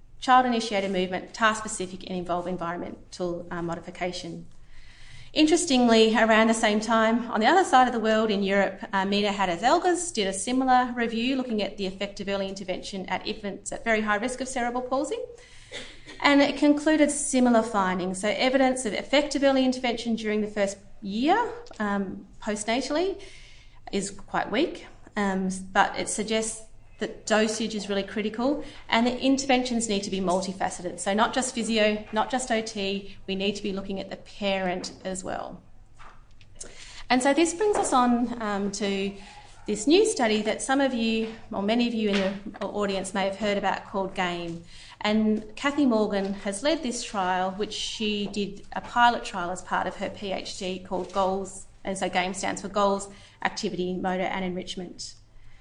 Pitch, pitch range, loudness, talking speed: 210 Hz, 190-240 Hz, -26 LUFS, 170 wpm